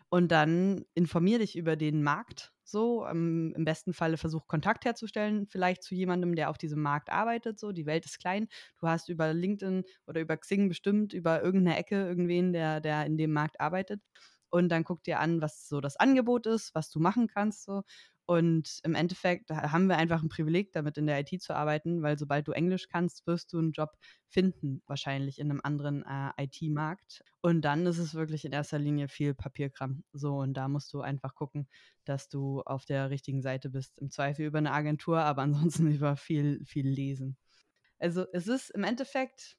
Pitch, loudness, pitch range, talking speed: 160 Hz, -32 LUFS, 145-180 Hz, 200 wpm